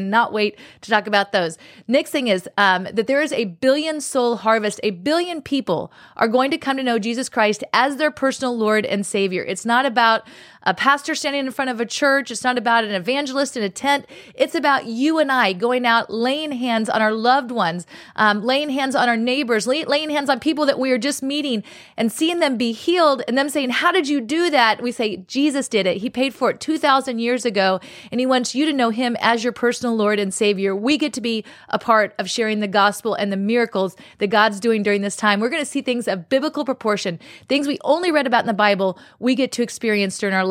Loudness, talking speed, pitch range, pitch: -19 LUFS, 240 wpm, 215-275 Hz, 240 Hz